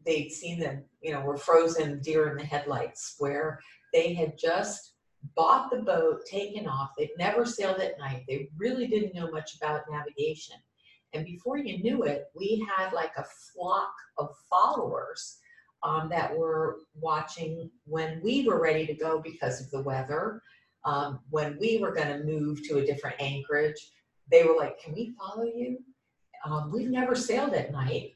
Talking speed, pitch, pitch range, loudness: 175 wpm, 160 Hz, 150-225 Hz, -30 LUFS